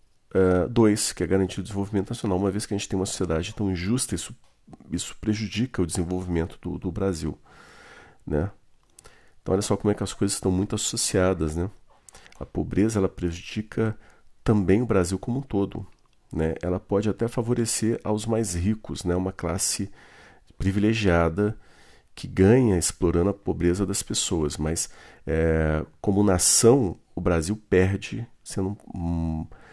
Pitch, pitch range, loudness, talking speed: 95 Hz, 90-105 Hz, -25 LUFS, 155 wpm